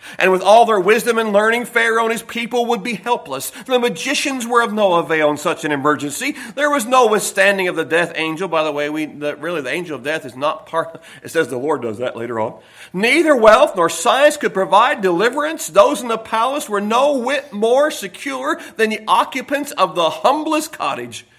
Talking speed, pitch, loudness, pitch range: 215 wpm, 210 Hz, -17 LUFS, 160-245 Hz